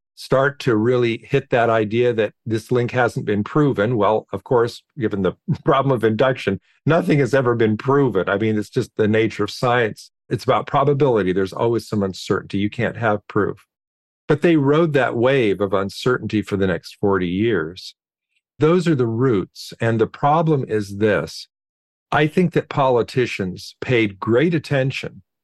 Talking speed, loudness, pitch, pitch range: 170 wpm, -19 LUFS, 115 Hz, 105-140 Hz